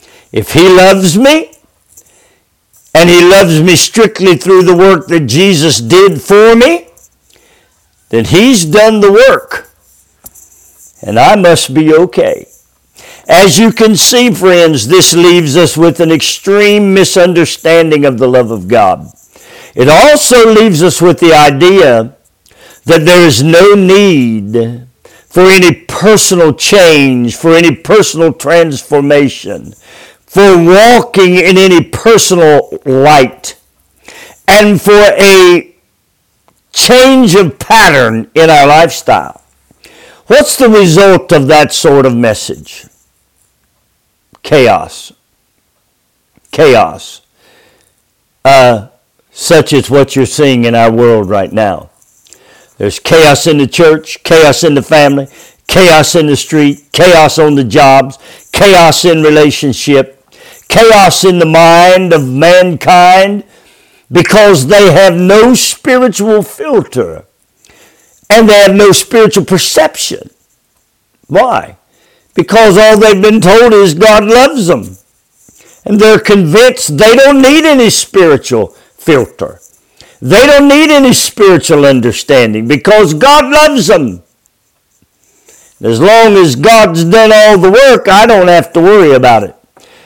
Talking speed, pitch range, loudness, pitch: 120 wpm, 150-210 Hz, -5 LUFS, 180 Hz